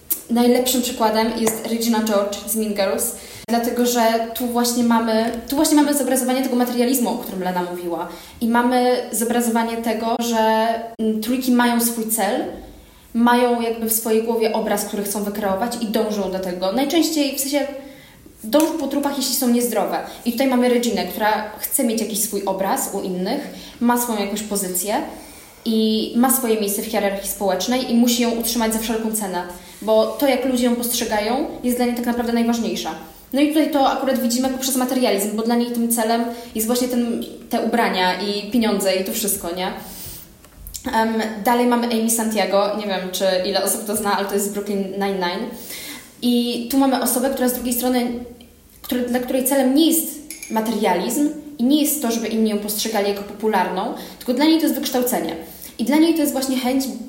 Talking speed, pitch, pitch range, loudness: 185 wpm, 235 Hz, 210-250 Hz, -20 LUFS